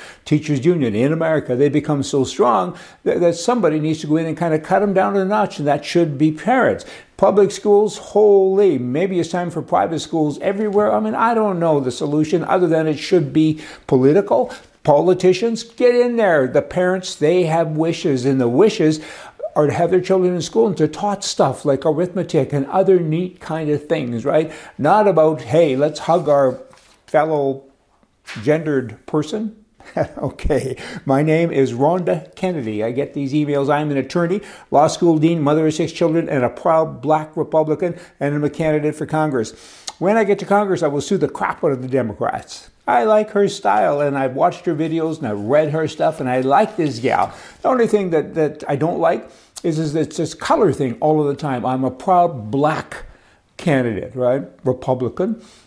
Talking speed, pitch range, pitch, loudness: 195 wpm, 145-185 Hz, 155 Hz, -18 LUFS